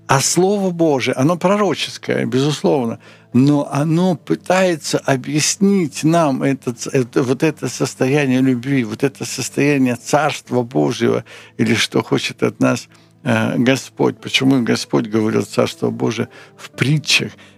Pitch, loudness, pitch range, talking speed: 135 Hz, -17 LUFS, 125-155 Hz, 120 wpm